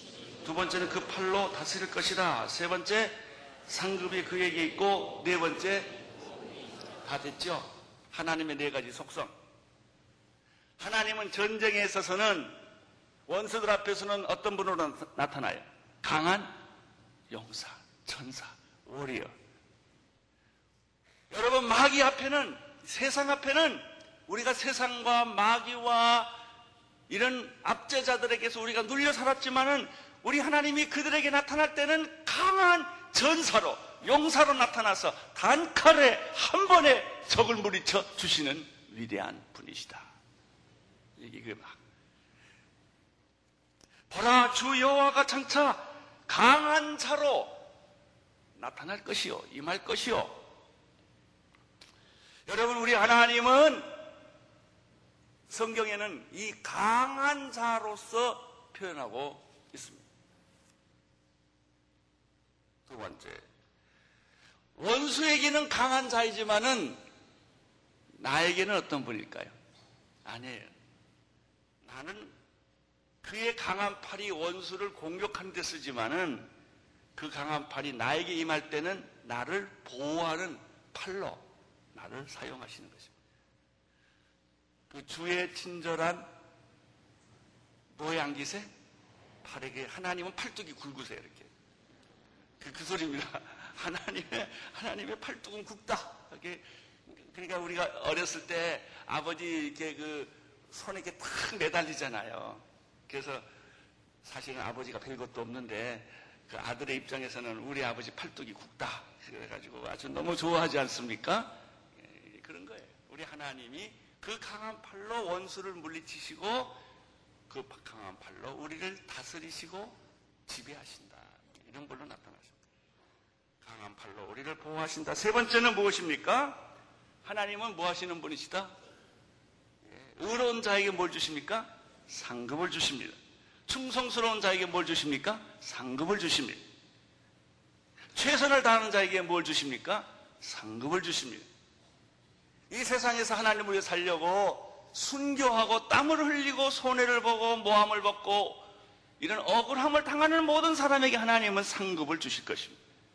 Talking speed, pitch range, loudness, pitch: 245 characters per minute, 155-255 Hz, -30 LUFS, 200 Hz